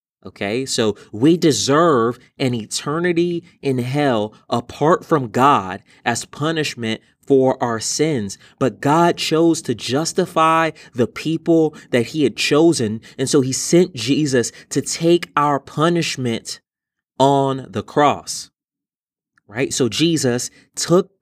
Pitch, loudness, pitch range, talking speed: 140 Hz, -18 LUFS, 125-160 Hz, 120 wpm